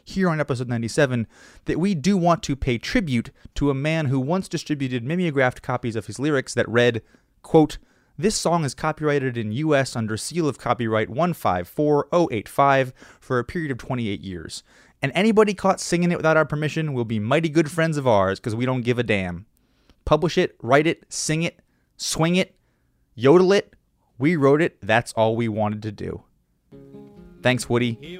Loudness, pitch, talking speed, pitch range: -22 LUFS, 135 Hz, 180 wpm, 115-160 Hz